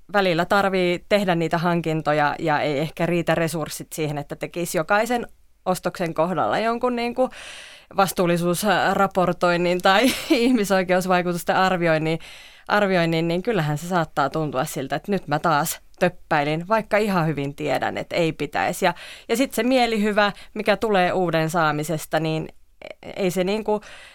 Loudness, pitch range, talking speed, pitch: -22 LUFS, 160-200 Hz, 135 wpm, 175 Hz